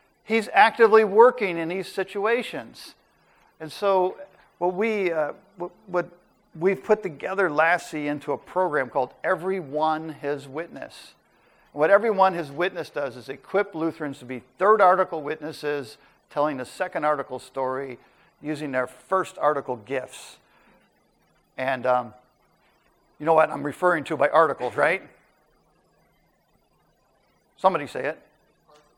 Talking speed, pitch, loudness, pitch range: 130 wpm, 165 Hz, -24 LUFS, 145-190 Hz